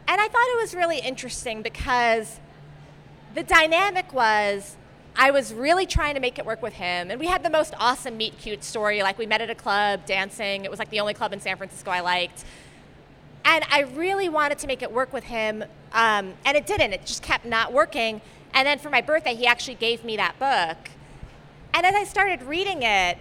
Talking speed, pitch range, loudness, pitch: 215 wpm, 210-305 Hz, -23 LUFS, 240 Hz